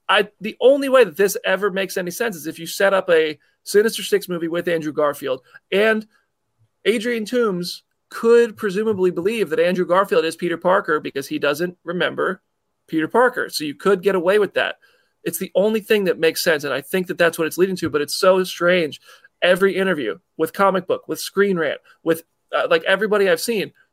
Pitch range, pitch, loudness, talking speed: 165-210 Hz, 190 Hz, -19 LUFS, 205 wpm